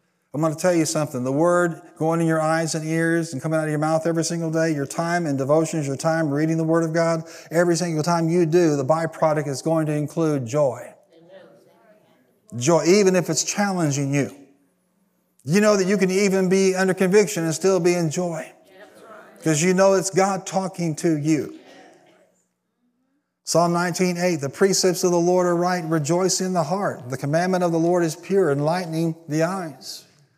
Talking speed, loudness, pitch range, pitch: 190 wpm, -21 LUFS, 160-185 Hz, 165 Hz